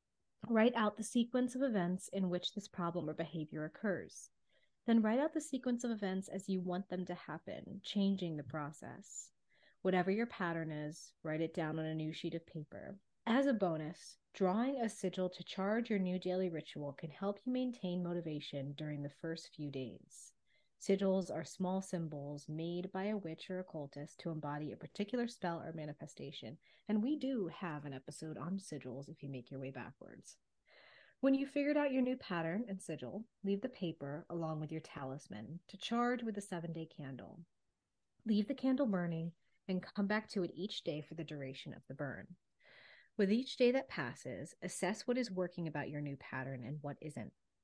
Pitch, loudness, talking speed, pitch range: 180 Hz, -40 LUFS, 190 wpm, 155-210 Hz